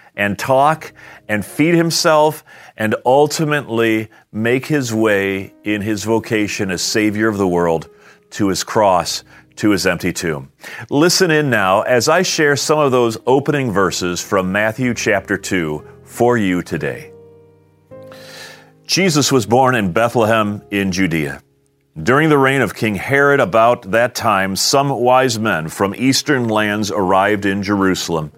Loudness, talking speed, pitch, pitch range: -15 LUFS, 145 wpm, 110 Hz, 95-135 Hz